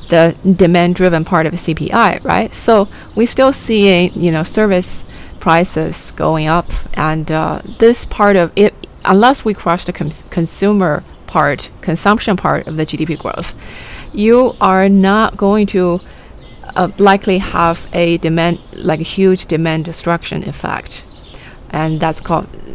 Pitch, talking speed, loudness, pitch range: 175 Hz, 150 wpm, -13 LUFS, 160-200 Hz